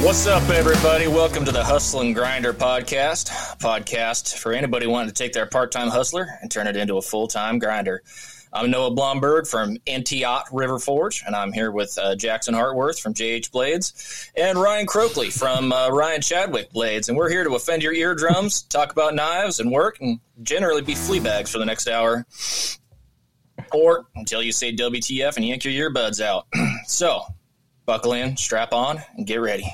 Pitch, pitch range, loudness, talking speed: 125 Hz, 115-150 Hz, -21 LUFS, 180 wpm